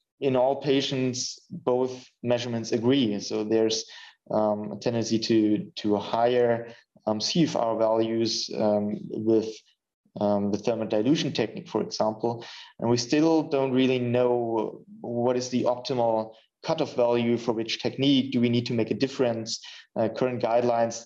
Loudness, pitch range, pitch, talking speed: -26 LUFS, 110-125 Hz, 120 Hz, 150 wpm